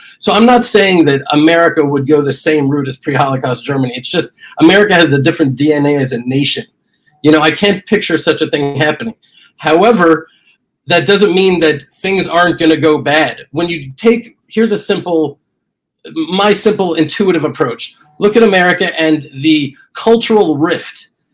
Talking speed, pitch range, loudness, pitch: 175 wpm, 150-200 Hz, -11 LUFS, 160 Hz